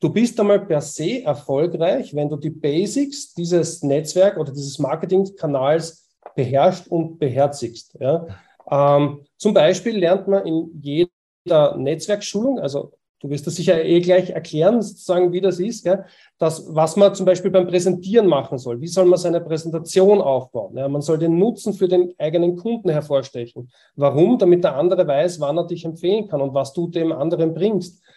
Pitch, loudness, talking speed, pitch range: 170 Hz, -19 LUFS, 175 wpm, 145-185 Hz